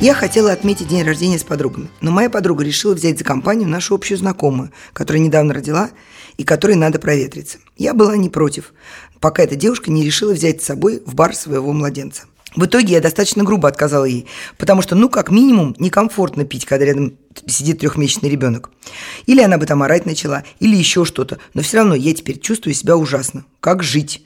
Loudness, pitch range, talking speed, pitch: -15 LUFS, 145-200 Hz, 195 wpm, 165 Hz